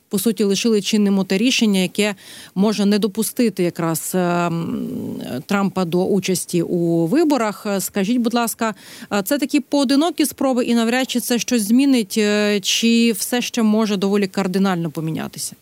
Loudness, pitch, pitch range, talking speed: -19 LUFS, 215 Hz, 195-235 Hz, 140 wpm